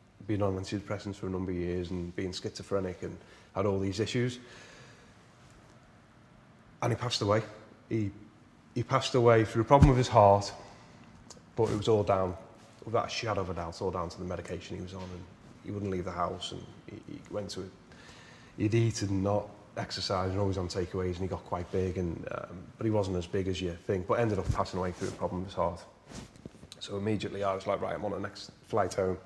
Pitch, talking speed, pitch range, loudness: 100 Hz, 220 wpm, 95-110 Hz, -31 LUFS